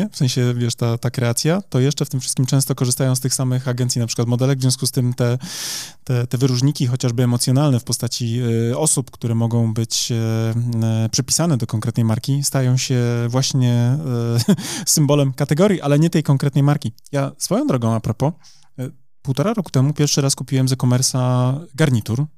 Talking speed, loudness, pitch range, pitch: 185 wpm, -19 LUFS, 120-140 Hz, 130 Hz